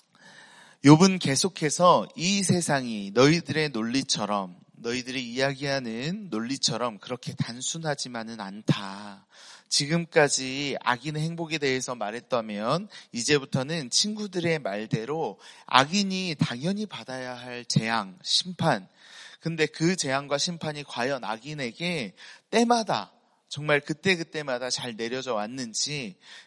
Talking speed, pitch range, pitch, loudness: 265 characters per minute, 125-175 Hz, 145 Hz, -26 LUFS